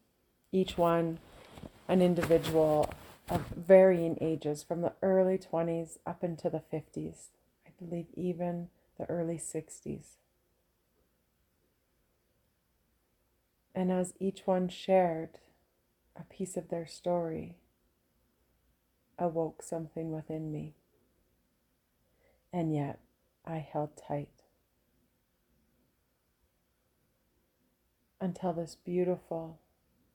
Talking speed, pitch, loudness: 85 wpm, 160 Hz, -32 LUFS